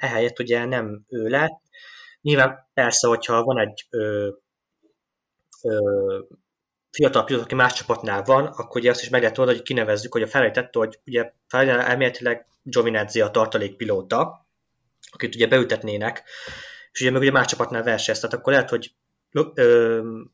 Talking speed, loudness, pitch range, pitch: 155 wpm, -21 LUFS, 115-130 Hz, 125 Hz